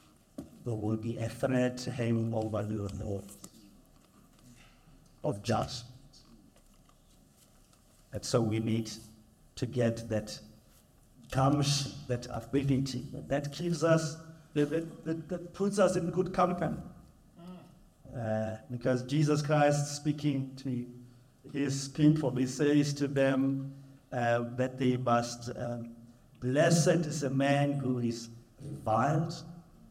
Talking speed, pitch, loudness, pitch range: 115 wpm, 130 Hz, -31 LUFS, 120-150 Hz